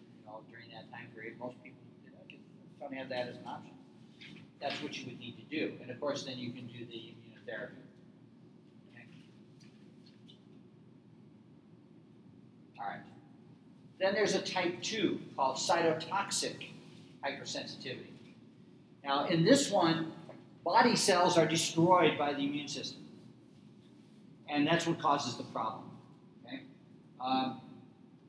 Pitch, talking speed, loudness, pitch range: 155 Hz, 130 wpm, -33 LUFS, 130-180 Hz